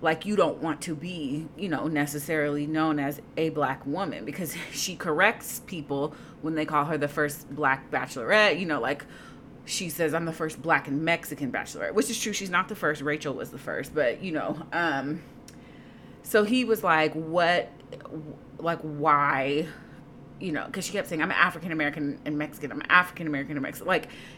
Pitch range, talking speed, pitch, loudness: 145-170 Hz, 190 wpm, 155 Hz, -27 LUFS